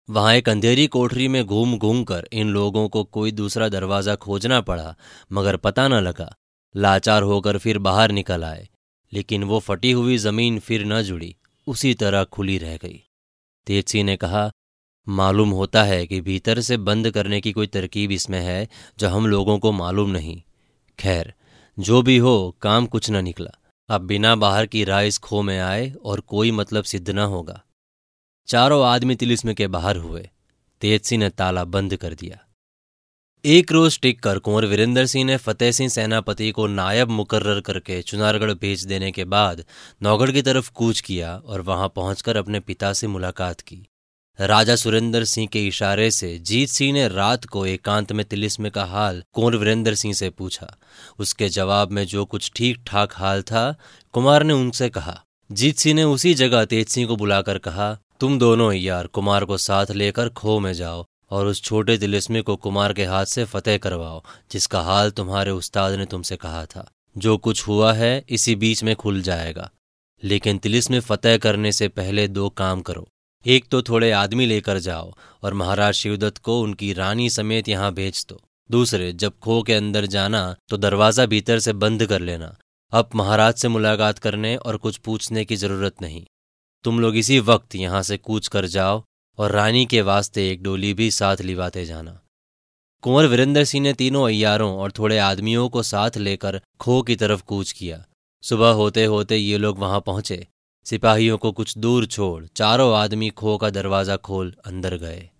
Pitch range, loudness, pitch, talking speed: 95-115 Hz, -20 LUFS, 105 Hz, 180 wpm